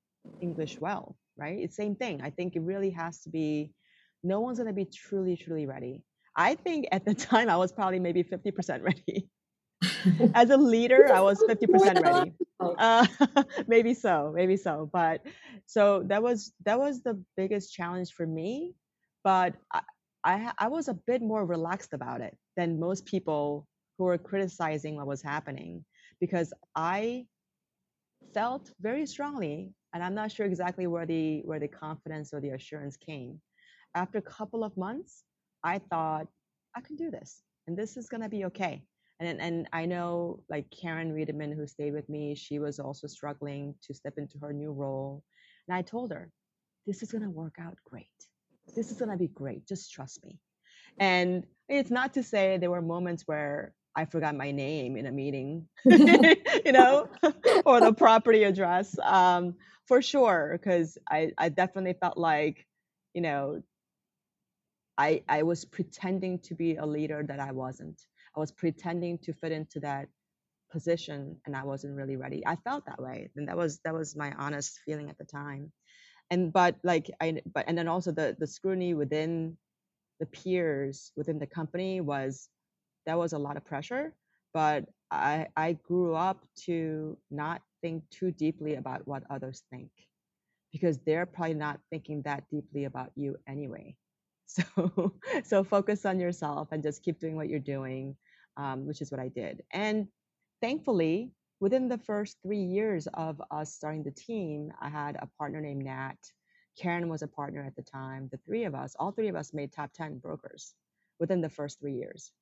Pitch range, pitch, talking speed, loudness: 150-200 Hz, 170 Hz, 180 wpm, -29 LUFS